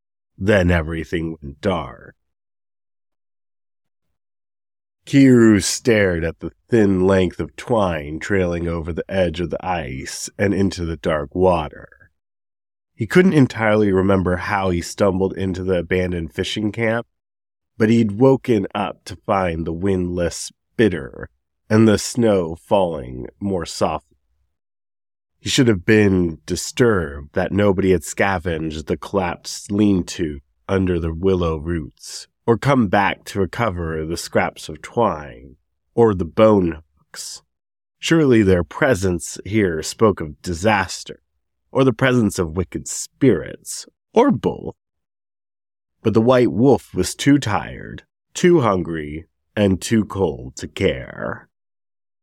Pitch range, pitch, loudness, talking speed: 80-105 Hz, 95 Hz, -19 LUFS, 125 wpm